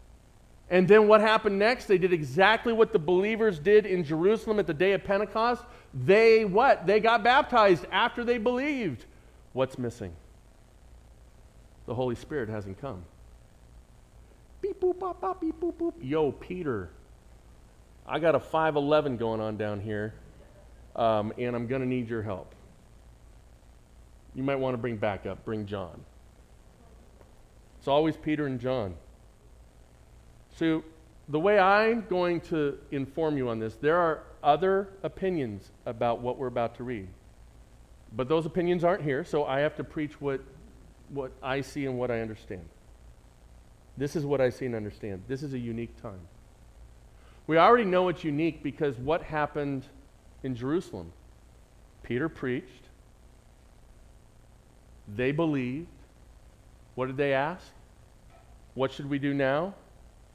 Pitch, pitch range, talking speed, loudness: 135 Hz, 110-180 Hz, 145 wpm, -27 LUFS